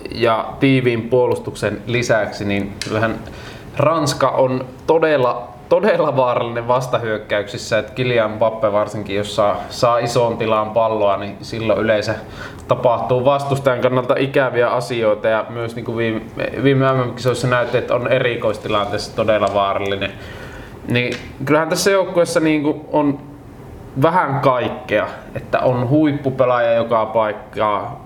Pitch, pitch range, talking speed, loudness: 120 Hz, 110-130 Hz, 115 wpm, -18 LUFS